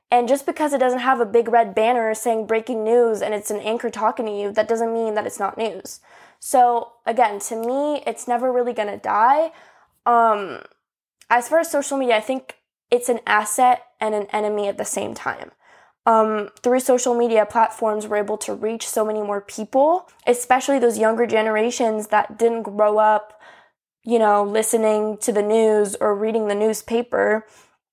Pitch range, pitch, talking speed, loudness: 215-245 Hz, 225 Hz, 185 wpm, -20 LUFS